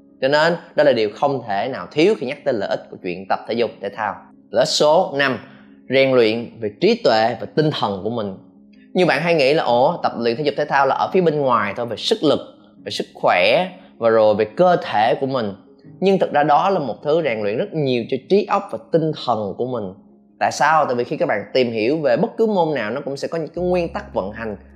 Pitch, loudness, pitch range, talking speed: 135 Hz, -19 LUFS, 105-160 Hz, 265 wpm